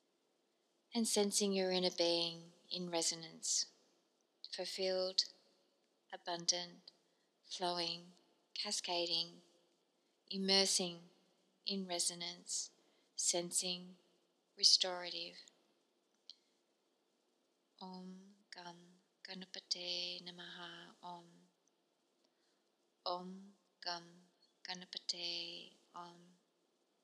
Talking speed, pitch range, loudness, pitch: 55 wpm, 175-190 Hz, -38 LUFS, 180 Hz